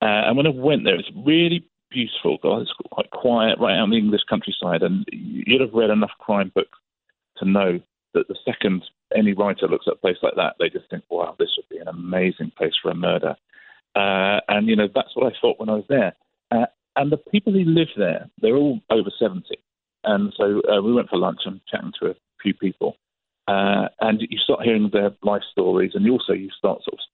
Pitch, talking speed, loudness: 110 Hz, 230 wpm, -21 LUFS